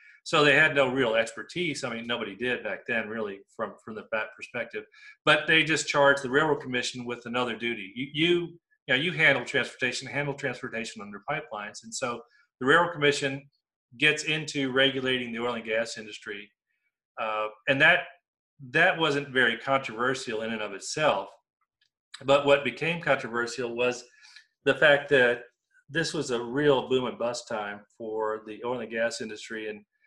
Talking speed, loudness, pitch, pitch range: 170 wpm, -26 LUFS, 130 Hz, 115-150 Hz